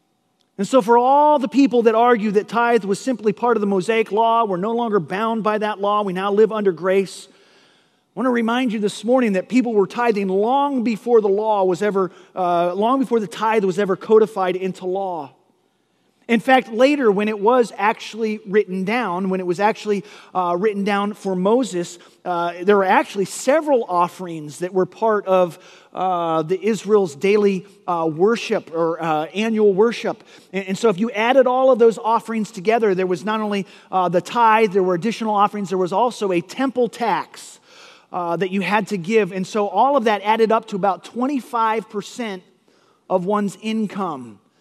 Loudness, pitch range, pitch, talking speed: -19 LUFS, 190-230 Hz, 210 Hz, 190 wpm